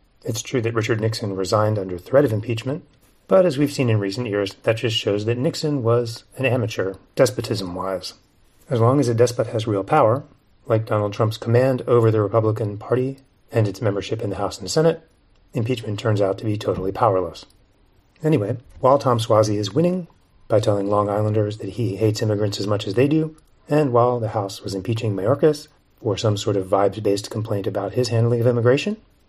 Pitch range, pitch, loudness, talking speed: 100-125 Hz, 110 Hz, -21 LUFS, 195 wpm